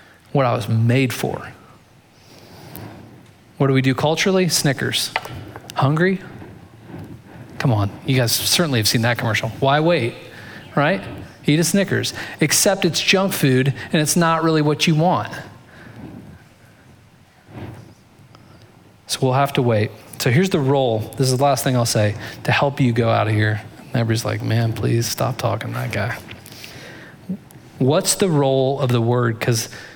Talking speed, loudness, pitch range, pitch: 155 wpm, -19 LUFS, 115-150 Hz, 130 Hz